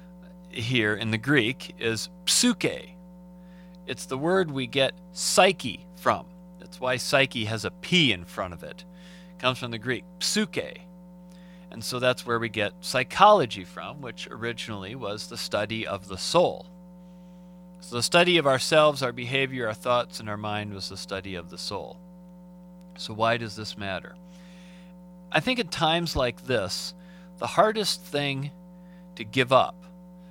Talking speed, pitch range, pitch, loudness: 160 wpm, 120-180 Hz, 175 Hz, -25 LUFS